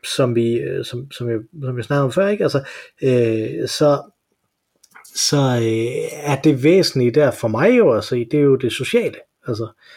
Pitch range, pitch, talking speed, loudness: 120-150 Hz, 135 Hz, 170 wpm, -18 LUFS